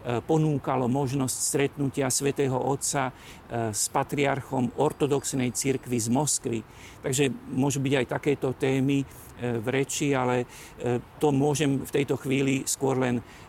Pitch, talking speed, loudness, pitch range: 135 Hz, 120 wpm, -27 LUFS, 125-140 Hz